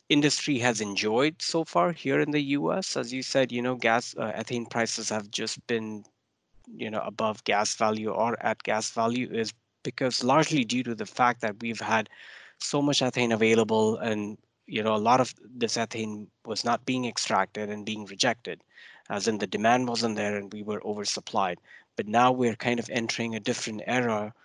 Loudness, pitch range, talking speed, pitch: -27 LUFS, 110-125 Hz, 190 wpm, 115 Hz